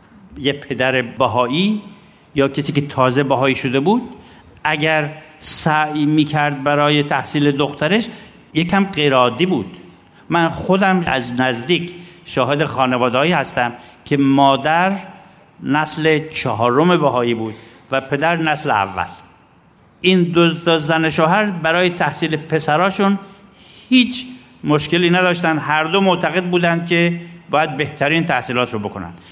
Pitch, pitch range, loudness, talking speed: 155 Hz, 135-175 Hz, -17 LUFS, 115 wpm